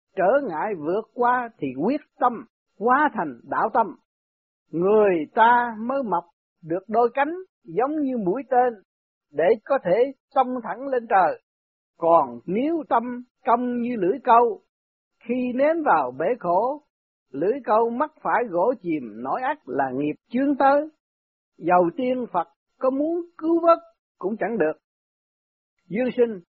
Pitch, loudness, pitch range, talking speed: 245 Hz, -23 LUFS, 195-280 Hz, 145 wpm